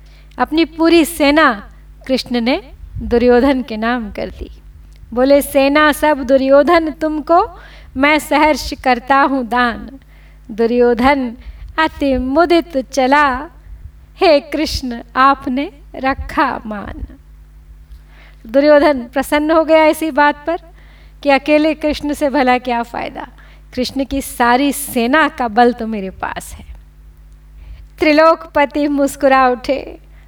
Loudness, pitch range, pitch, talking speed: -14 LUFS, 240-300 Hz, 275 Hz, 110 wpm